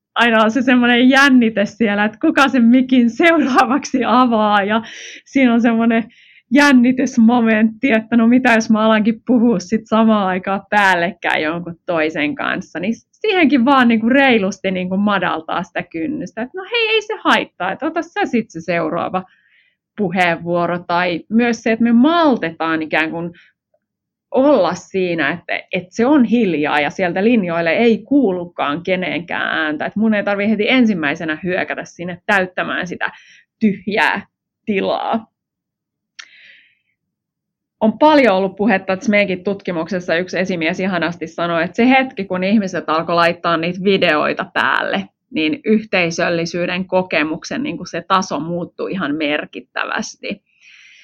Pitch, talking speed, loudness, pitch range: 210 Hz, 140 wpm, -16 LUFS, 175-245 Hz